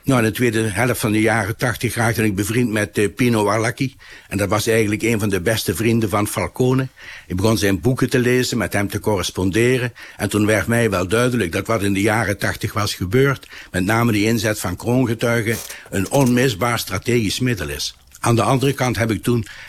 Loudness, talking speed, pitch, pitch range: -19 LUFS, 205 wpm, 110 Hz, 105-120 Hz